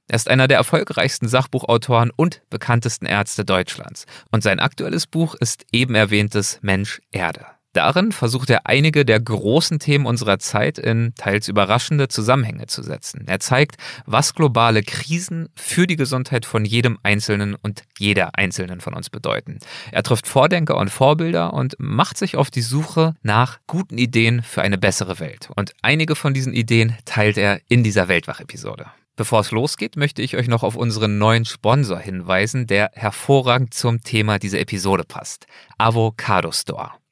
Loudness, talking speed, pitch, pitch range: -18 LUFS, 160 wpm, 120 Hz, 105-135 Hz